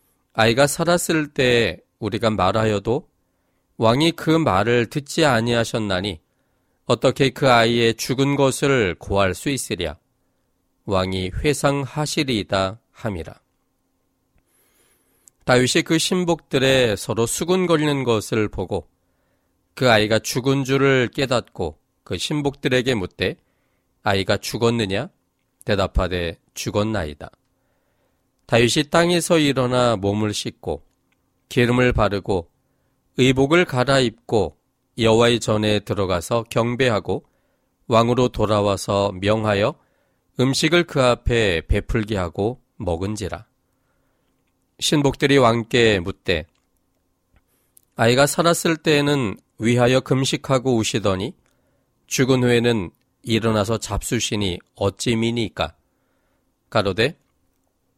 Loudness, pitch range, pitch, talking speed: -20 LUFS, 100-135 Hz, 115 Hz, 230 characters per minute